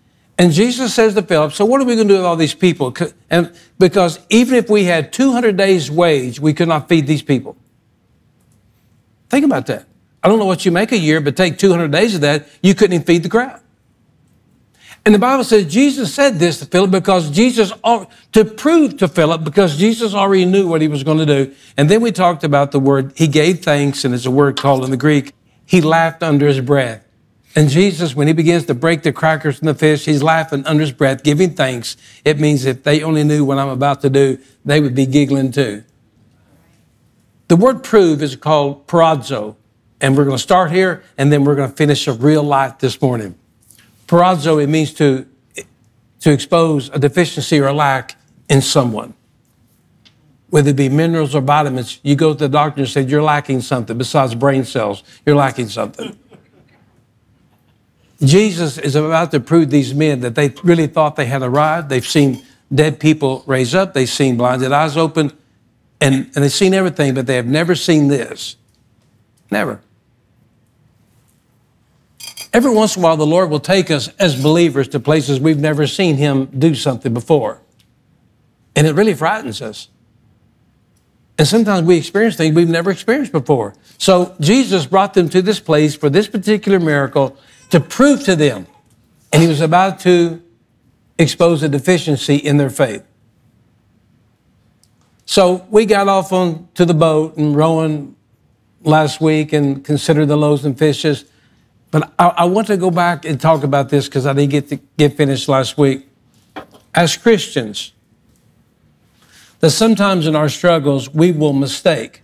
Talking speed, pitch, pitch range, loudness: 180 wpm, 150 Hz, 135-175 Hz, -14 LUFS